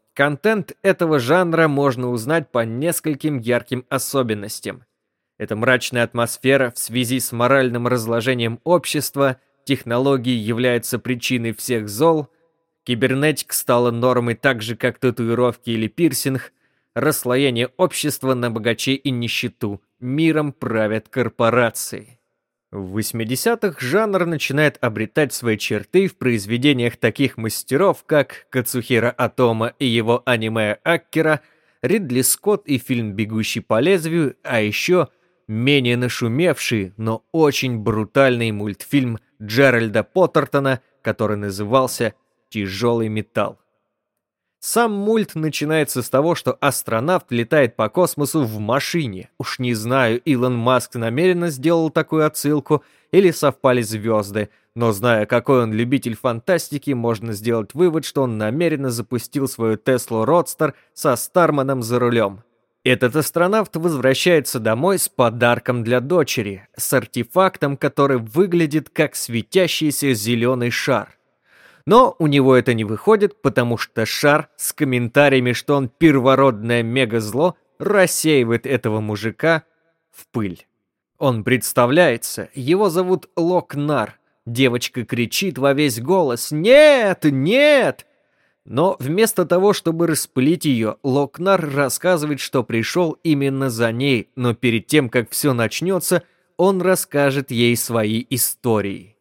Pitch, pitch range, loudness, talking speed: 130 Hz, 115-155 Hz, -19 LUFS, 120 wpm